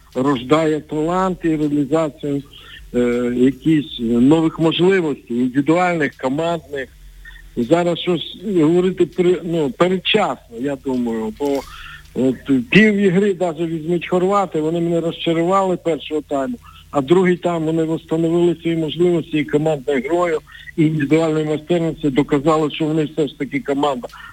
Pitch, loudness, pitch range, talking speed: 155 Hz, -18 LUFS, 145-175 Hz, 120 wpm